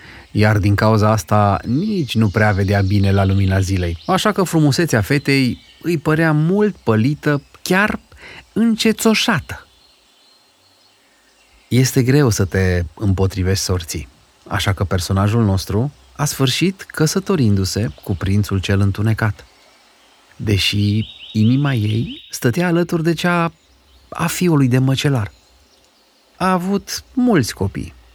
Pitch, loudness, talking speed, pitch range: 110 Hz, -17 LUFS, 115 wpm, 100-160 Hz